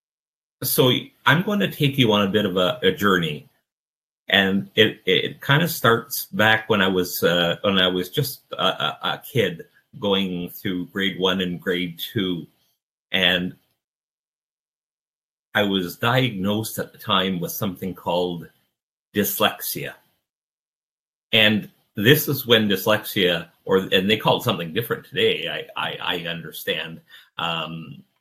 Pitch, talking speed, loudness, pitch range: 95 Hz, 145 wpm, -21 LUFS, 90-120 Hz